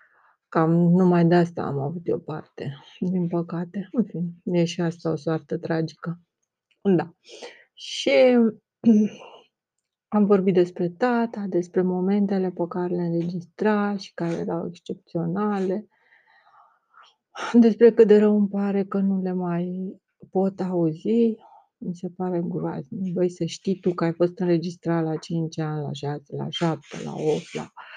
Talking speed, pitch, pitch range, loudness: 140 wpm, 180 Hz, 170-205 Hz, -23 LUFS